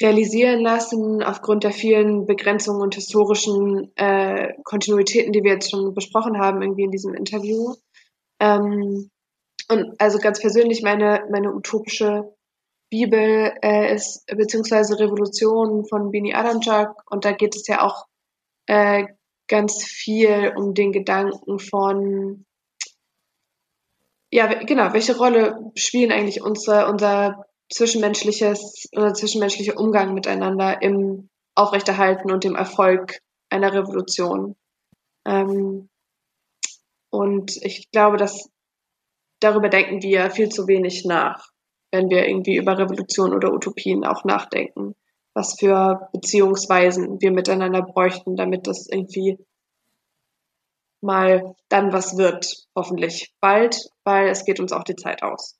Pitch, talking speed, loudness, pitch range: 200 Hz, 120 wpm, -20 LUFS, 195-210 Hz